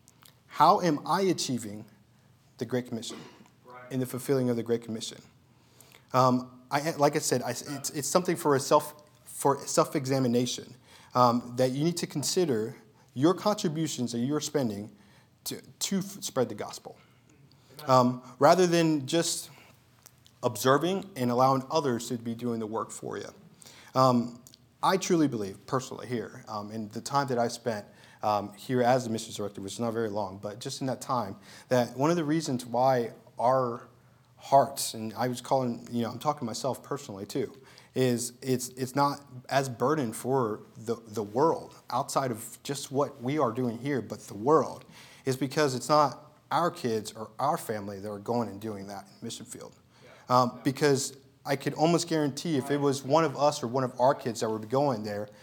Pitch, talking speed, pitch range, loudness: 130 Hz, 185 wpm, 120-145 Hz, -29 LUFS